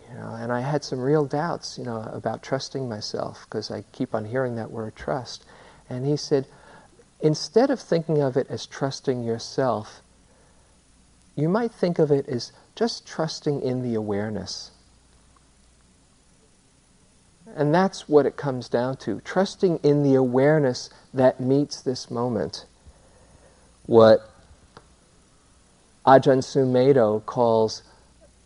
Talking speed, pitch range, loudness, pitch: 130 wpm, 110-145 Hz, -23 LUFS, 130 Hz